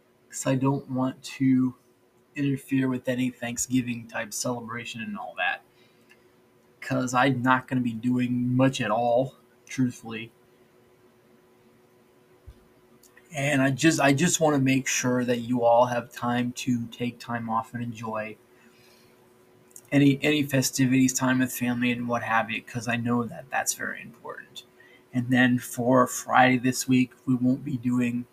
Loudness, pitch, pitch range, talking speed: -25 LUFS, 125 Hz, 120-130 Hz, 155 wpm